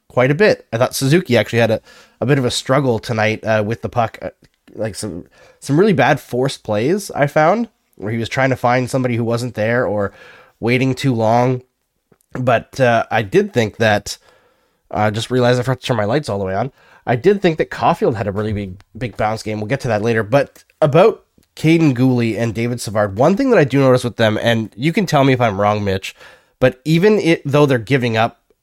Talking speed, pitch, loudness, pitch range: 235 wpm, 120 Hz, -16 LUFS, 110-135 Hz